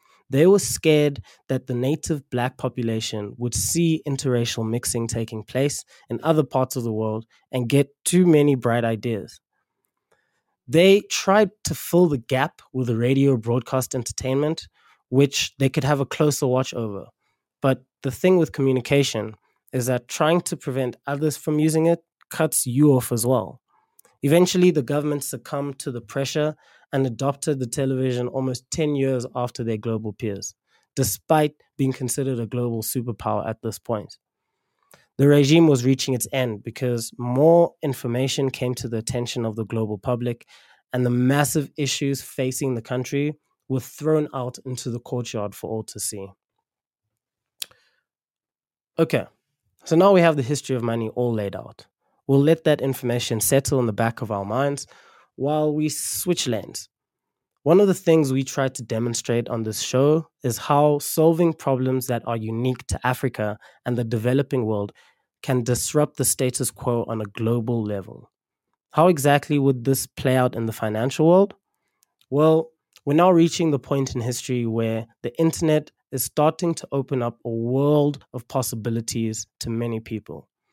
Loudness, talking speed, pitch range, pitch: -22 LUFS, 160 wpm, 120-145 Hz, 130 Hz